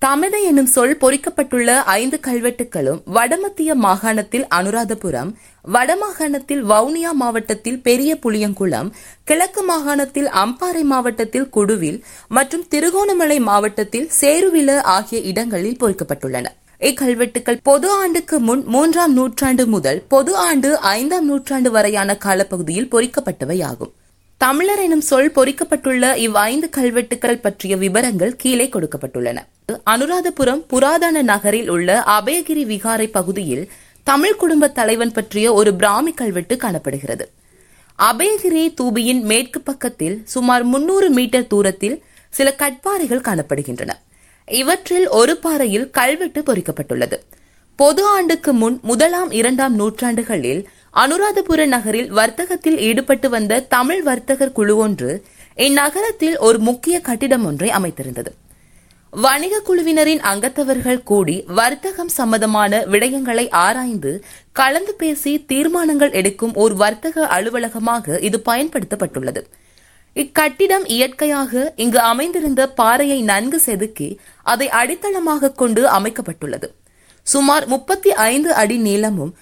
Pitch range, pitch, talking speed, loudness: 215-295 Hz, 250 Hz, 105 wpm, -16 LUFS